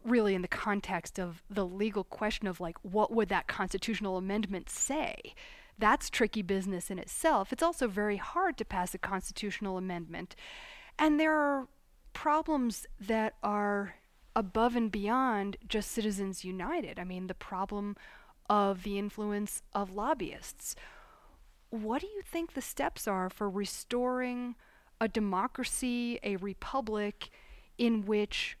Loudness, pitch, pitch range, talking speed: -33 LUFS, 210 Hz, 195-245 Hz, 140 wpm